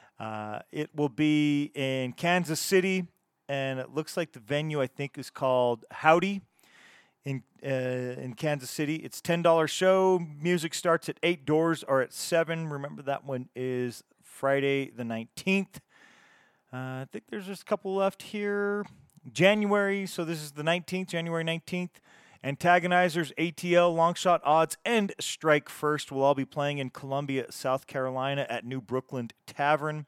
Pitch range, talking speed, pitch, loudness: 135-175 Hz, 155 wpm, 150 Hz, -28 LUFS